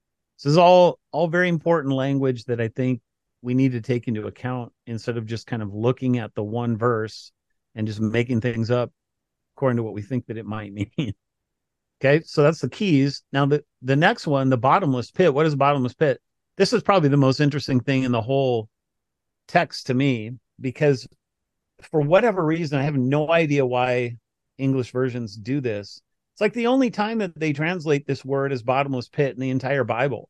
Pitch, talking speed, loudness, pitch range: 130 Hz, 200 wpm, -22 LUFS, 120-145 Hz